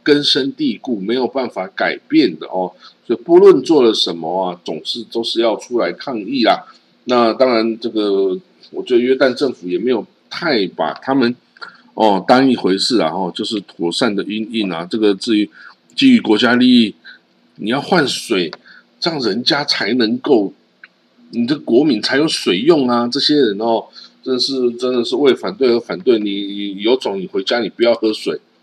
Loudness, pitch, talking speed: -16 LUFS, 120 Hz, 255 characters per minute